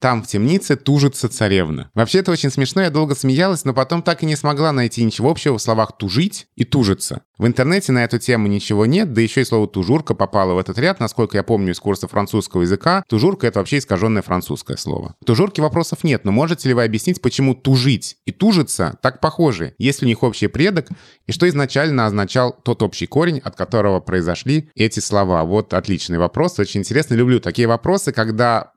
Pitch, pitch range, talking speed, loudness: 120 Hz, 105-145 Hz, 200 wpm, -17 LUFS